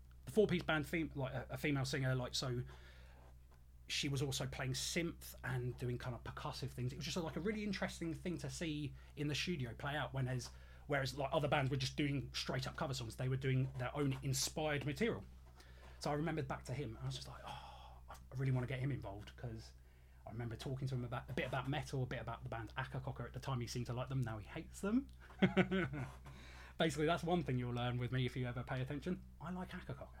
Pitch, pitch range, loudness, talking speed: 130 Hz, 120-150 Hz, -41 LUFS, 235 wpm